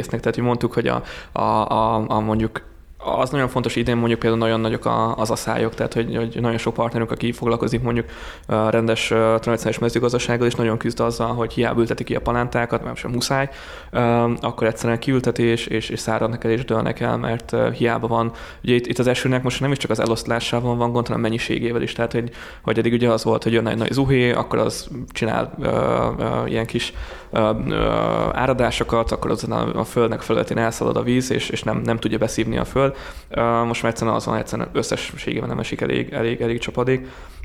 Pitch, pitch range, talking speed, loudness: 115 Hz, 110-120 Hz, 205 wpm, -21 LUFS